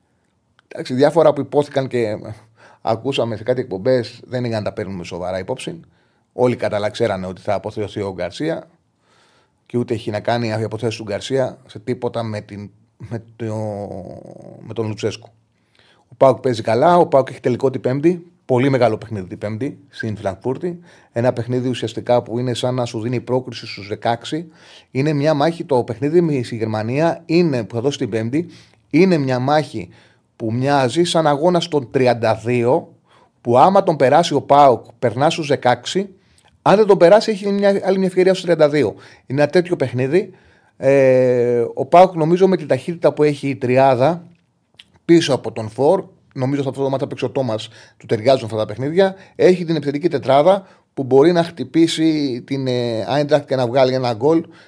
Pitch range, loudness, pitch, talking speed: 115-155 Hz, -18 LUFS, 130 Hz, 170 wpm